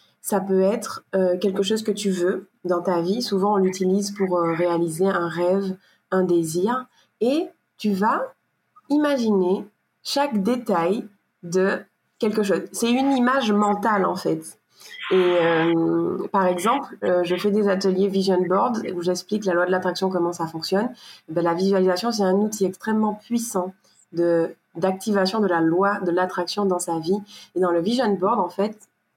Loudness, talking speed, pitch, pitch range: -22 LUFS, 170 wpm, 190 Hz, 180-210 Hz